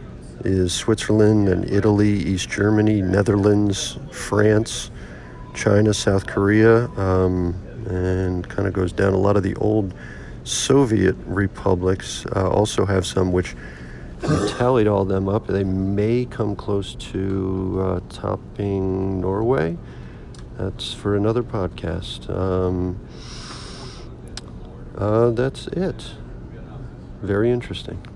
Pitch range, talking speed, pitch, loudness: 95-105 Hz, 110 wpm, 100 Hz, -21 LUFS